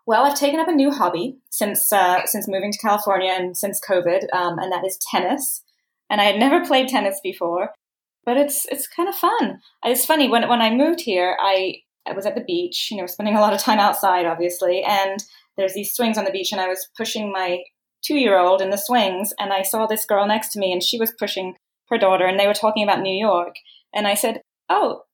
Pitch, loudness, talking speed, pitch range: 205 Hz, -20 LUFS, 230 wpm, 190-245 Hz